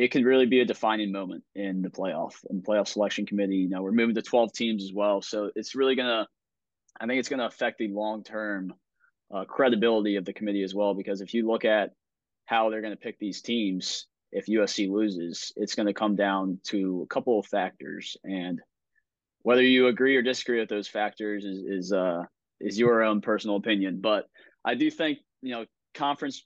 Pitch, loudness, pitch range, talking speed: 105 Hz, -27 LUFS, 100-115 Hz, 205 wpm